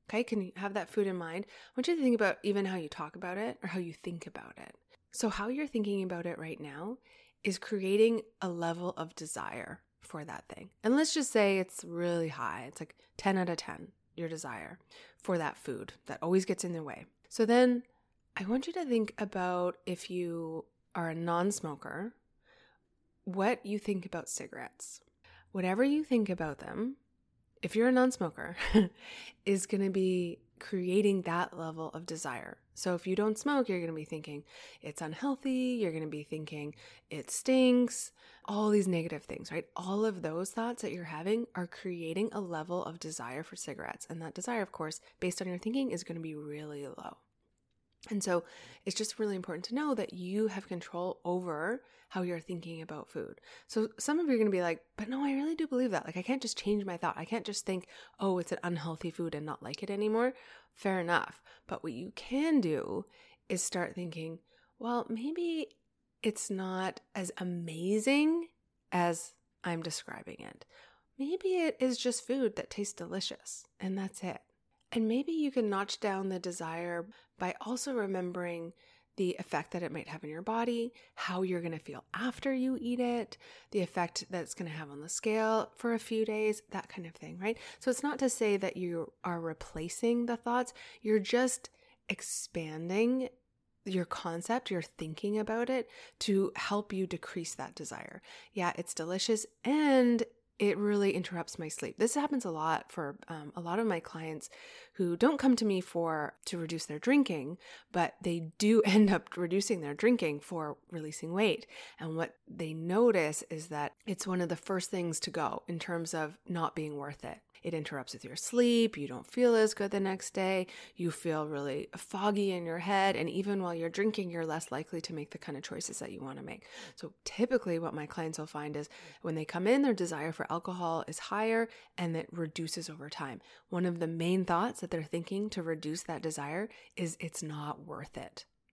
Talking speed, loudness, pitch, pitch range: 200 wpm, -34 LUFS, 185 Hz, 165-225 Hz